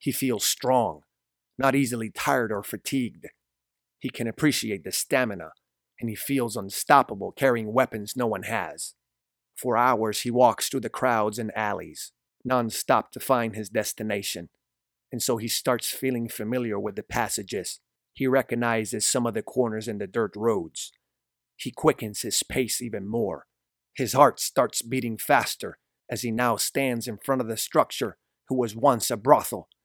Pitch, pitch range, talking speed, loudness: 120 Hz, 110-130 Hz, 165 wpm, -26 LUFS